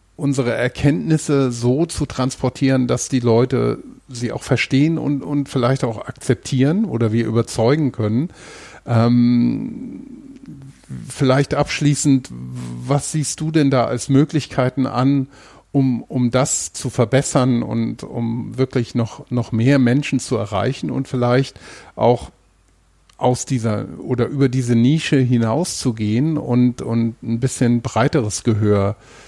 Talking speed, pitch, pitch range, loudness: 125 wpm, 130 Hz, 115-140 Hz, -18 LUFS